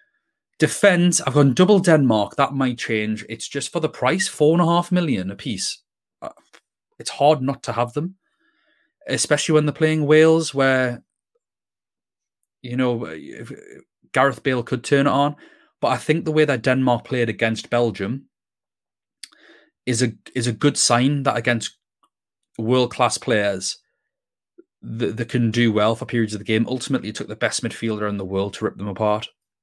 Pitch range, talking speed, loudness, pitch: 115-155 Hz, 170 wpm, -20 LUFS, 130 Hz